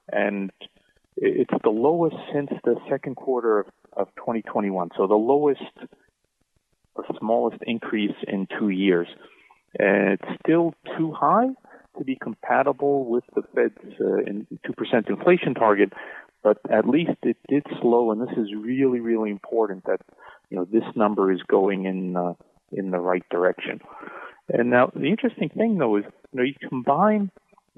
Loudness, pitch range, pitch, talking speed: -23 LUFS, 105-160 Hz, 125 Hz, 155 wpm